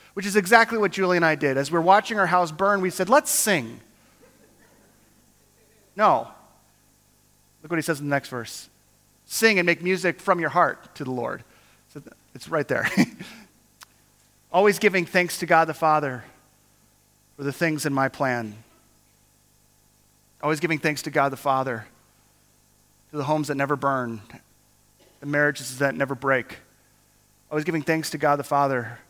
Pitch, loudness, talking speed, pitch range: 140 Hz, -23 LUFS, 165 wpm, 125-170 Hz